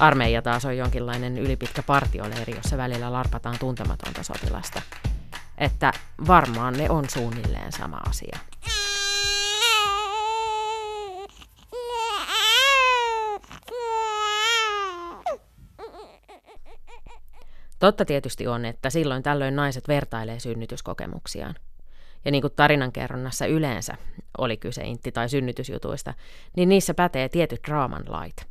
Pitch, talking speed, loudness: 145 Hz, 90 wpm, -24 LUFS